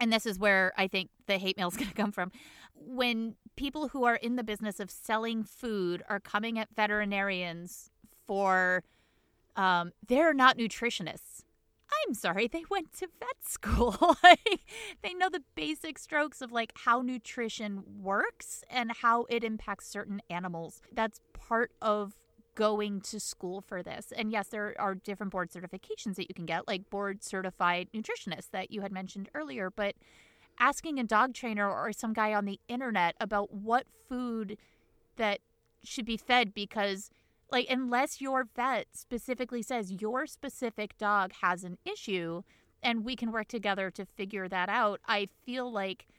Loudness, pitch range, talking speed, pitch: -31 LUFS, 195-245 Hz, 165 wpm, 215 Hz